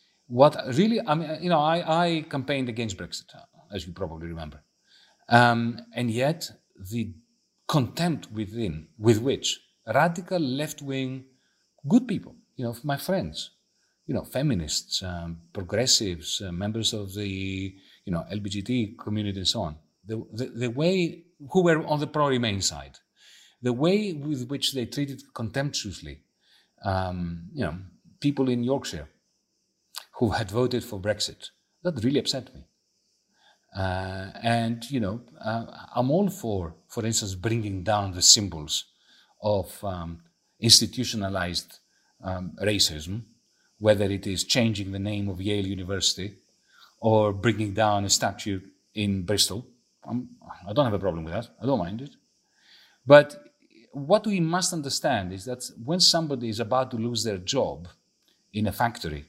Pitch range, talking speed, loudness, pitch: 95-135 Hz, 145 wpm, -26 LUFS, 115 Hz